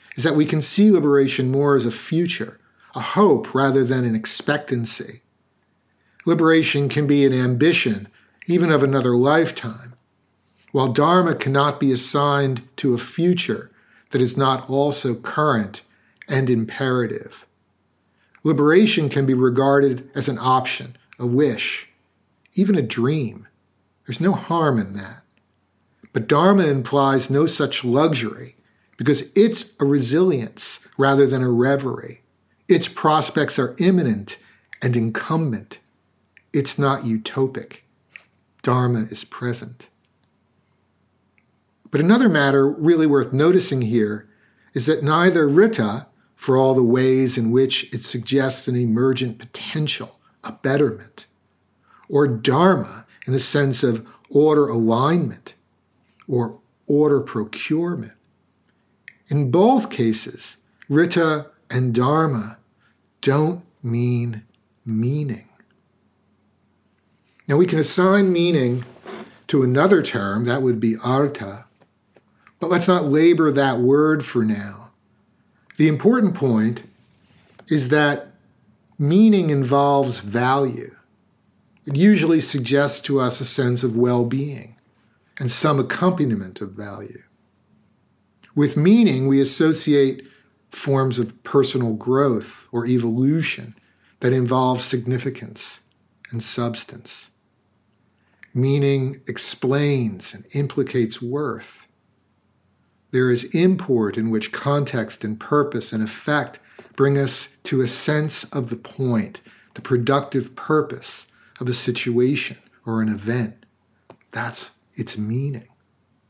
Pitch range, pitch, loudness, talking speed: 120-145 Hz, 130 Hz, -19 LUFS, 115 wpm